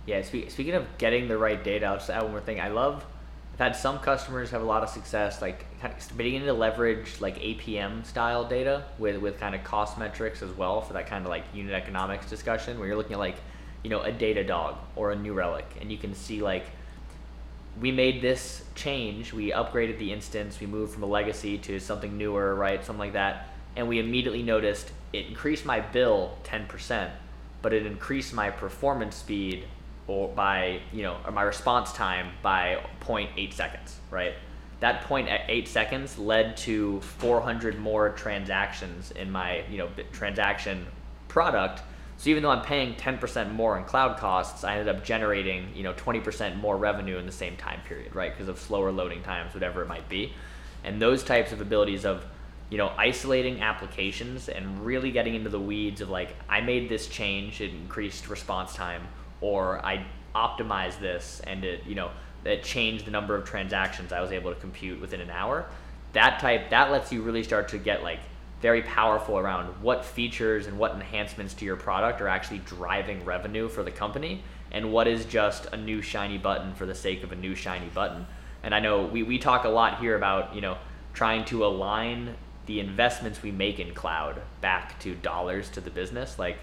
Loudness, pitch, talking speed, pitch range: -29 LUFS, 105 Hz, 200 wpm, 95-115 Hz